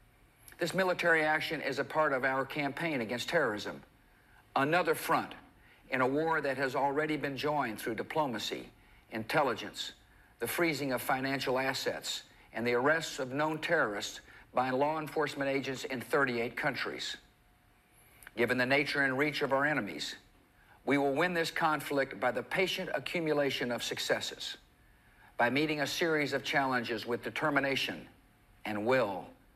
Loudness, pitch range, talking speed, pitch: -32 LUFS, 130-155 Hz, 145 wpm, 140 Hz